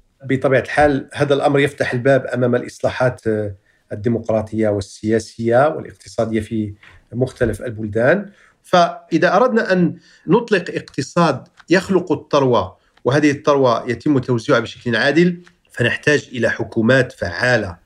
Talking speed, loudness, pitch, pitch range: 105 wpm, -18 LUFS, 130 Hz, 115-155 Hz